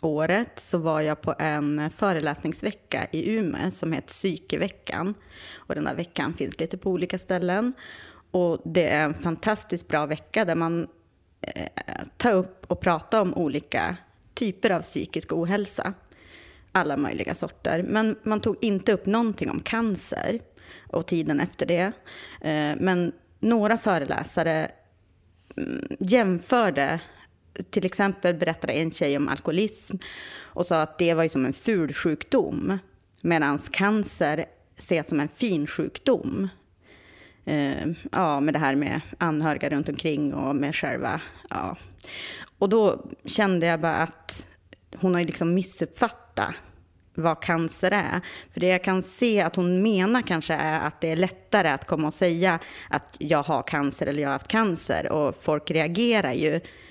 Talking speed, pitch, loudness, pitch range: 150 wpm, 165 Hz, -26 LUFS, 150-195 Hz